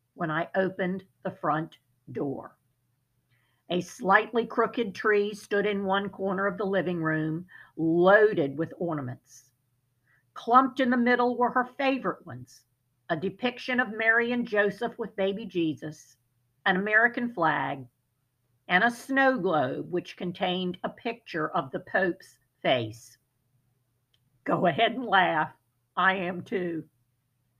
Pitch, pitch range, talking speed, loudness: 175 Hz, 125-215 Hz, 130 wpm, -27 LUFS